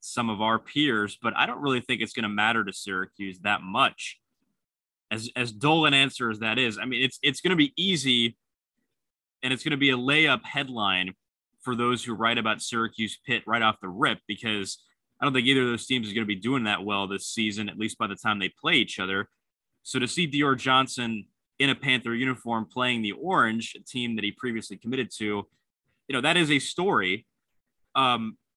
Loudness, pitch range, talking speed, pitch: -25 LUFS, 110-130 Hz, 220 wpm, 120 Hz